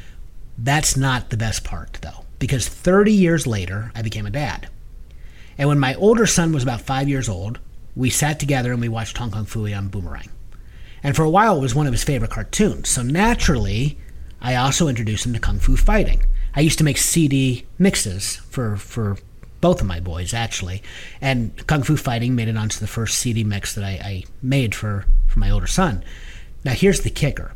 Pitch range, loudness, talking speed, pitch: 100-140 Hz, -20 LUFS, 200 wpm, 115 Hz